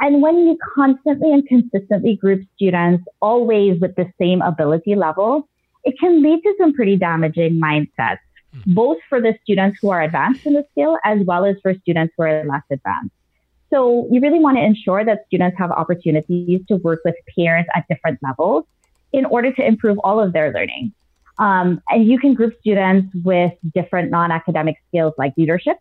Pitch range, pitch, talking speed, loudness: 170-240 Hz, 195 Hz, 180 wpm, -17 LUFS